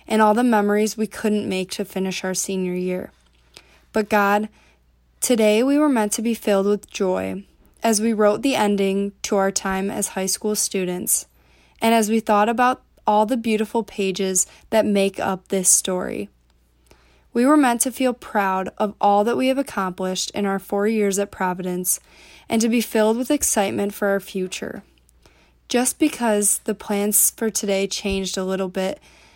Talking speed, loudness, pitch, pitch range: 175 wpm, -20 LUFS, 205 Hz, 190-220 Hz